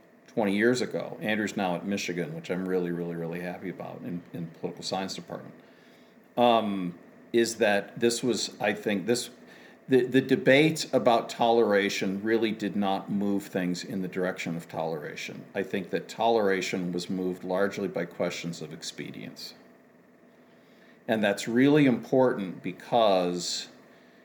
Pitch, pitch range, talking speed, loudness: 100 Hz, 90-120 Hz, 145 wpm, -28 LUFS